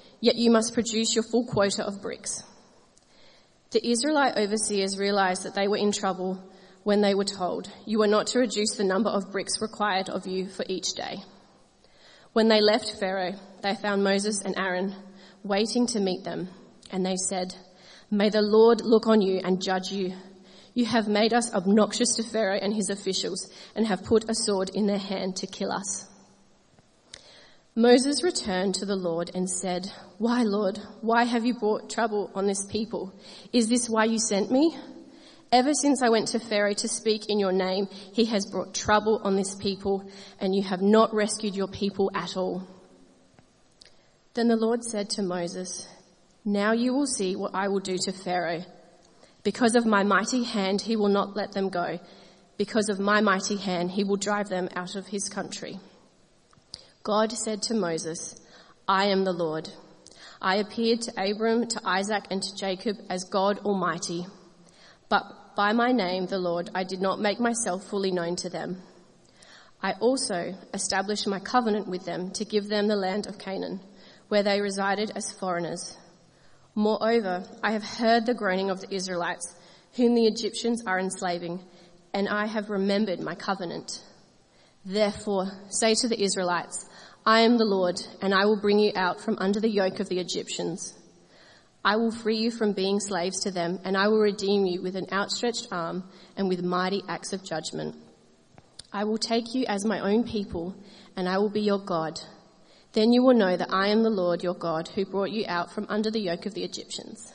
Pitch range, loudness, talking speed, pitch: 185-215 Hz, -26 LUFS, 185 wpm, 200 Hz